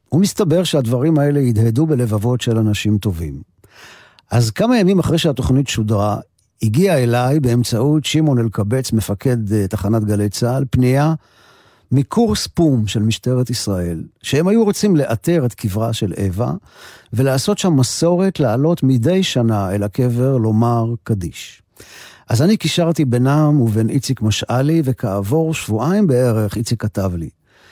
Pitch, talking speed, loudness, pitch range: 125 Hz, 130 wpm, -17 LUFS, 110-155 Hz